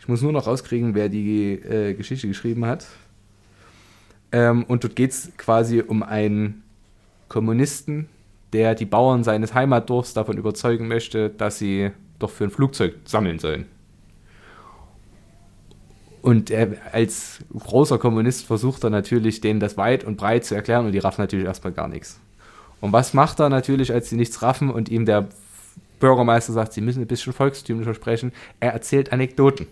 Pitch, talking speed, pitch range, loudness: 115 Hz, 165 wpm, 105-125 Hz, -21 LUFS